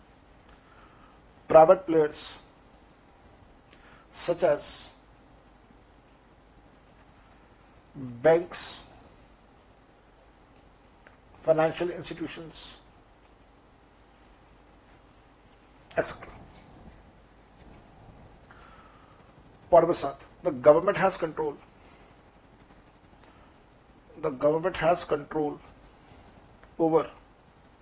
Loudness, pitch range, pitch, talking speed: -26 LUFS, 150-170 Hz, 160 Hz, 40 wpm